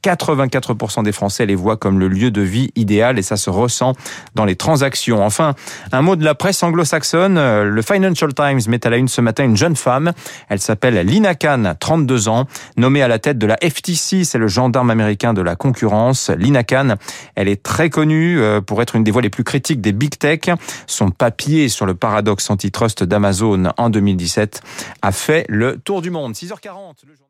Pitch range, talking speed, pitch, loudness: 105-150 Hz, 200 wpm, 125 Hz, -15 LUFS